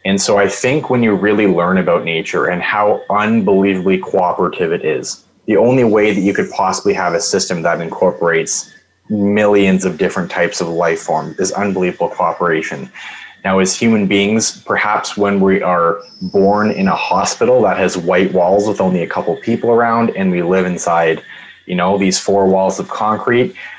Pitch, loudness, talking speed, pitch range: 100 Hz, -14 LUFS, 180 wpm, 95-105 Hz